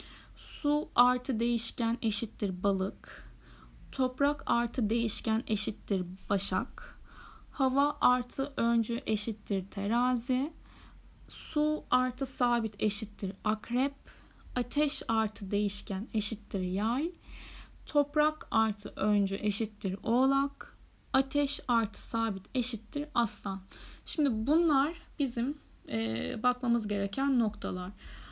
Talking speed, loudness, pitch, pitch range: 85 wpm, -31 LUFS, 235 Hz, 210-265 Hz